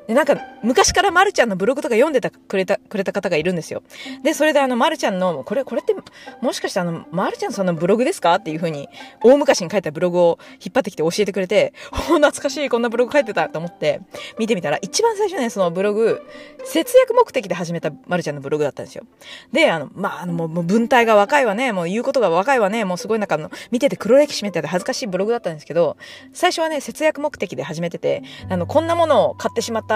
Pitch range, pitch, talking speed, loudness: 180-290 Hz, 230 Hz, 500 characters per minute, -19 LUFS